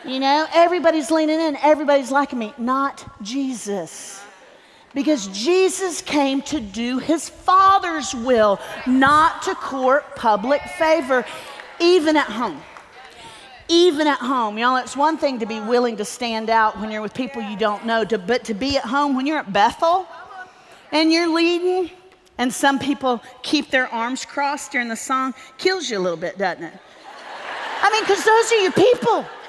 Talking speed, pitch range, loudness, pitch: 170 wpm, 240-330 Hz, -19 LUFS, 275 Hz